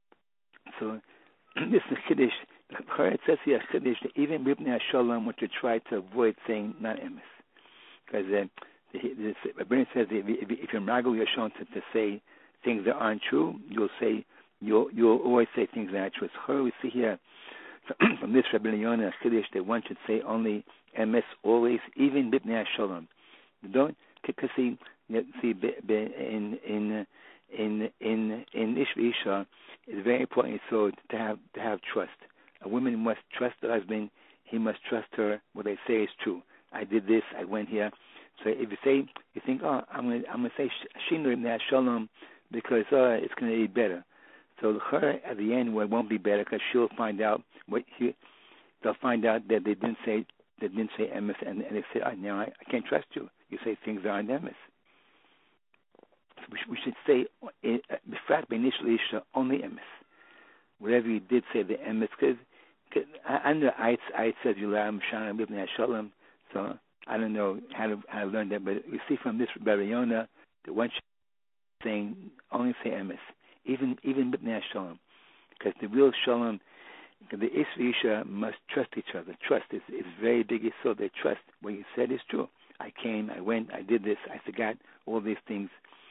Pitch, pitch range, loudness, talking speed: 110 Hz, 105-120 Hz, -30 LUFS, 180 wpm